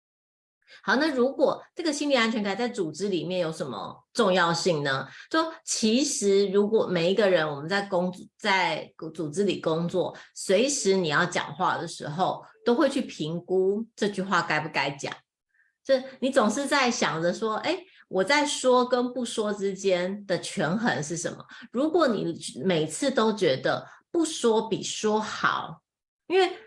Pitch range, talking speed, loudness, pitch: 180-260 Hz, 225 characters per minute, -26 LUFS, 205 Hz